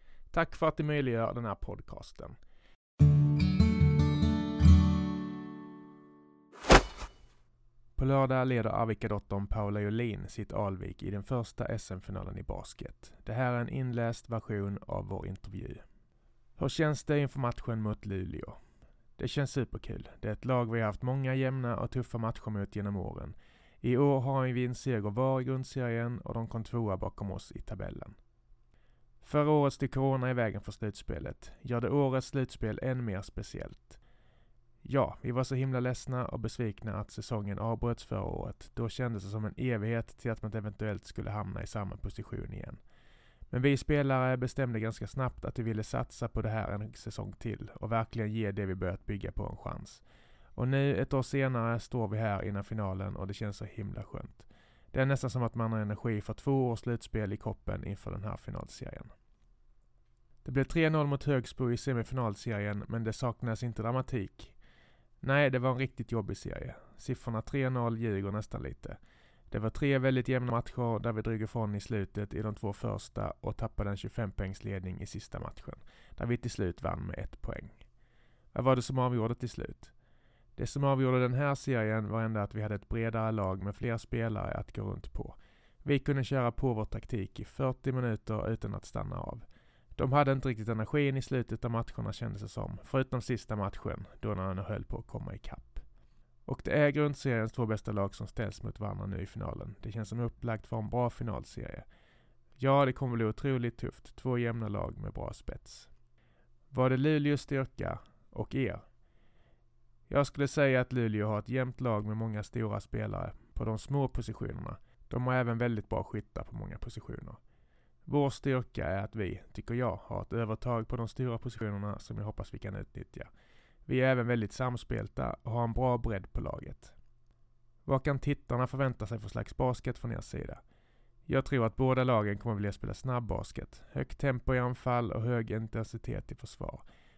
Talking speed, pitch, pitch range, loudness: 185 wpm, 115 Hz, 105-130 Hz, -34 LUFS